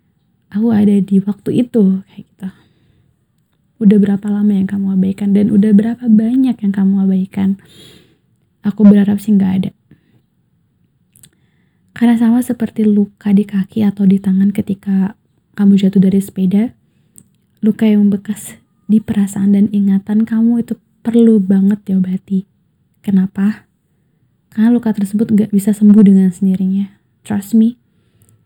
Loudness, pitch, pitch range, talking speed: -13 LUFS, 200 Hz, 195-215 Hz, 130 wpm